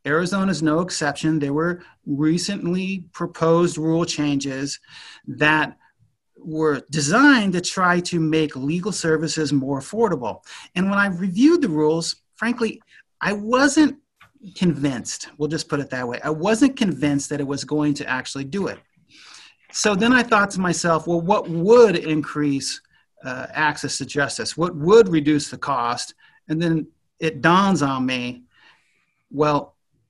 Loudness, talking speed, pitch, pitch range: -20 LUFS, 150 wpm, 160 Hz, 145-190 Hz